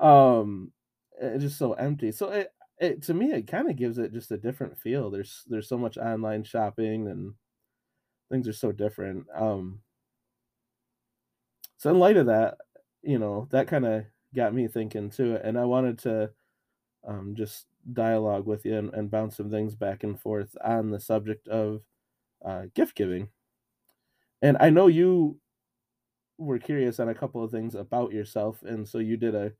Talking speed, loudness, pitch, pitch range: 175 wpm, -27 LUFS, 115 Hz, 105-125 Hz